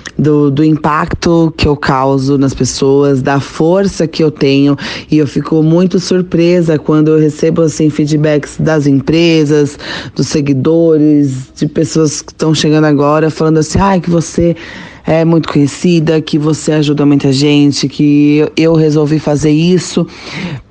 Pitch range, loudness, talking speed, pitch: 145-160 Hz, -10 LUFS, 150 wpm, 155 Hz